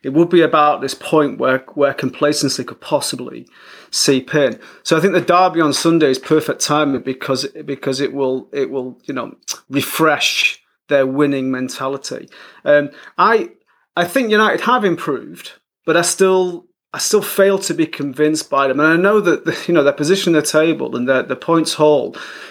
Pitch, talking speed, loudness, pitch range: 150 Hz, 185 wpm, -16 LUFS, 140-175 Hz